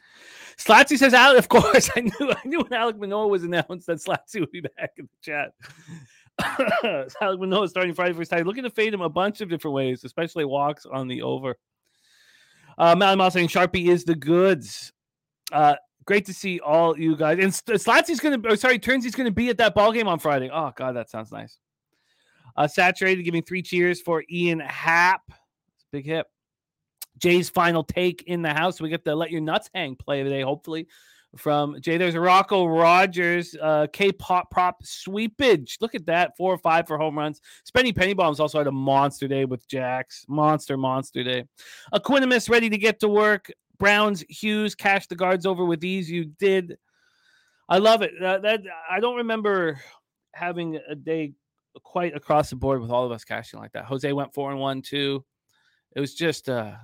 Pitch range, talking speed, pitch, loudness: 150-200 Hz, 195 wpm, 175 Hz, -22 LUFS